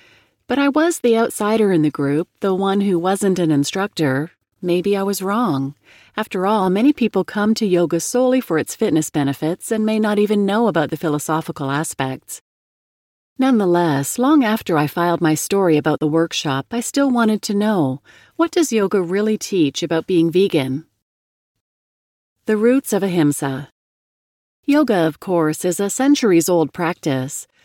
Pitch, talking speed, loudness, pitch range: 180 Hz, 160 wpm, -18 LUFS, 155-215 Hz